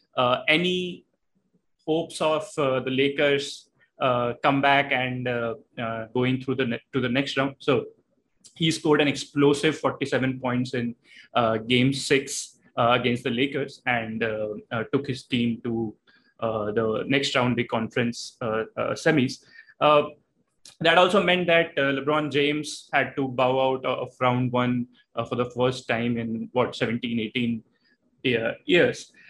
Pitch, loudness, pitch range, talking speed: 130 Hz, -24 LUFS, 120-145 Hz, 160 wpm